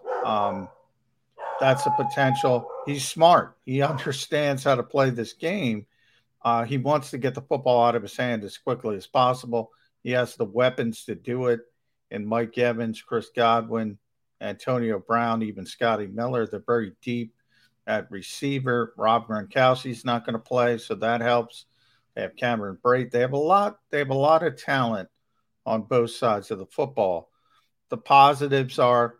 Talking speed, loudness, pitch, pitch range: 165 wpm, -24 LUFS, 125 Hz, 115-135 Hz